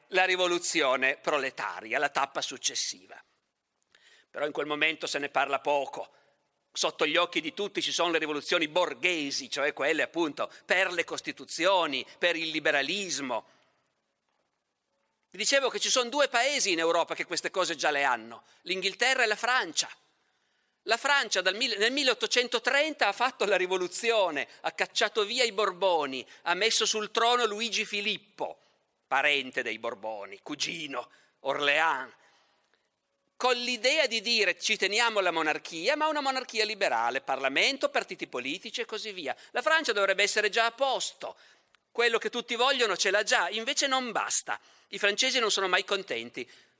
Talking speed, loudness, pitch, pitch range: 155 wpm, -27 LUFS, 215 Hz, 180-245 Hz